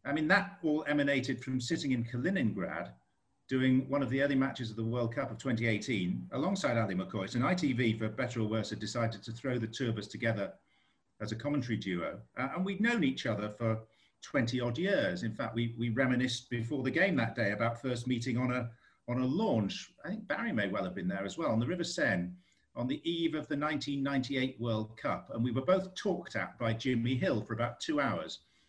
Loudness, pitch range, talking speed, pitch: -33 LUFS, 115-135 Hz, 225 wpm, 120 Hz